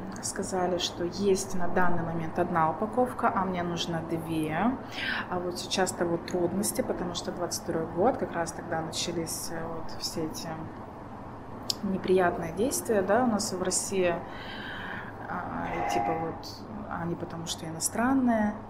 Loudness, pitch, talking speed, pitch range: -30 LUFS, 175 Hz, 140 wpm, 160-195 Hz